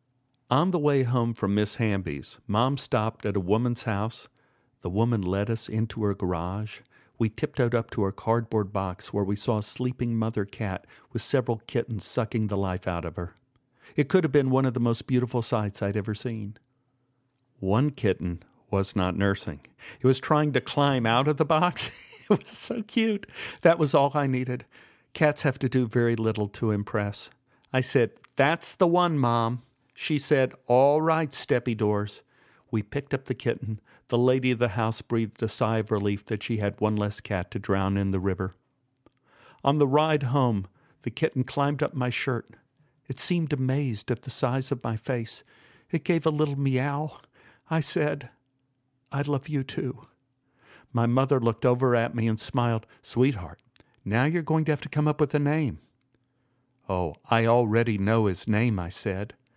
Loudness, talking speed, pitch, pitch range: -26 LUFS, 185 wpm, 125 Hz, 110-135 Hz